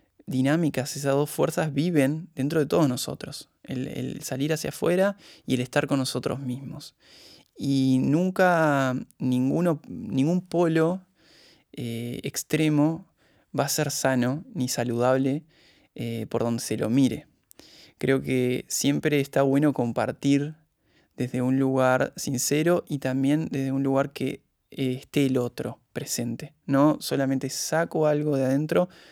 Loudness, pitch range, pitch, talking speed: -25 LUFS, 130-155 Hz, 140 Hz, 135 wpm